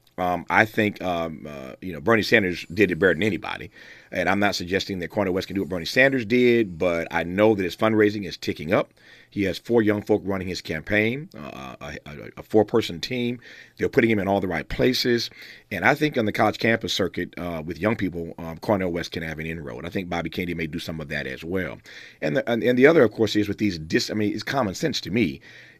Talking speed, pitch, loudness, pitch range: 250 wpm, 100 Hz, -23 LUFS, 85-110 Hz